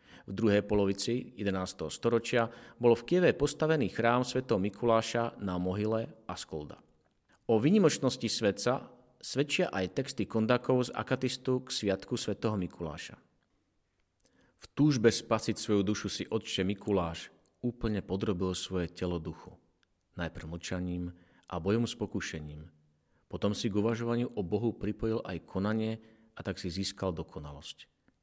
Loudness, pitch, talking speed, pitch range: -32 LUFS, 105 Hz, 130 wpm, 90-115 Hz